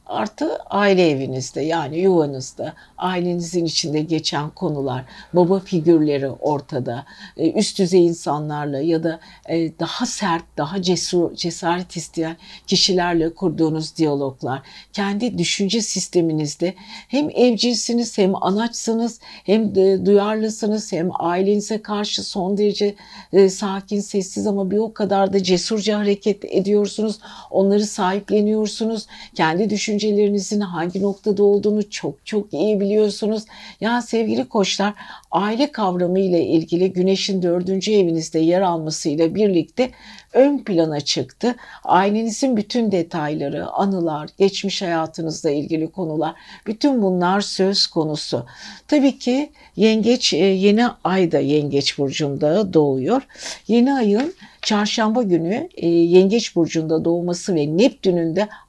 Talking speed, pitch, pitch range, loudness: 115 wpm, 195 Hz, 165-215 Hz, -19 LUFS